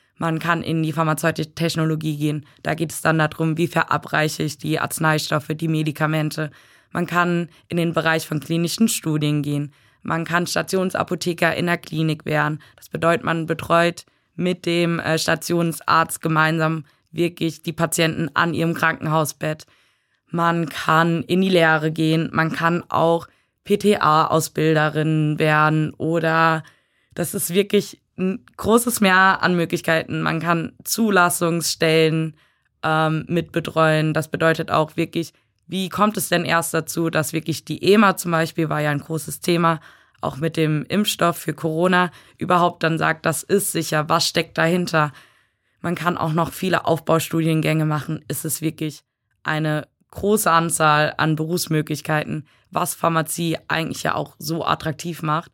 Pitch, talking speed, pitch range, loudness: 160 Hz, 145 wpm, 155-170 Hz, -20 LUFS